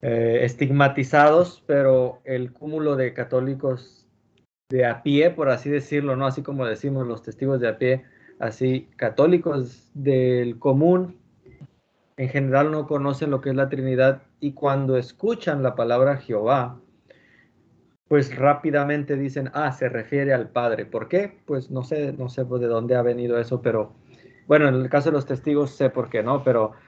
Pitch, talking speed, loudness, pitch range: 135 Hz, 165 wpm, -22 LUFS, 125-145 Hz